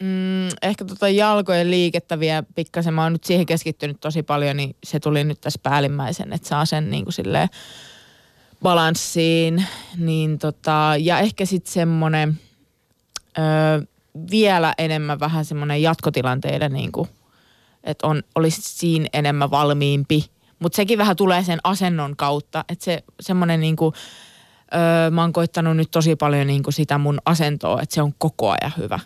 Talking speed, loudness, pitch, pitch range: 145 wpm, -20 LUFS, 160 Hz, 150-175 Hz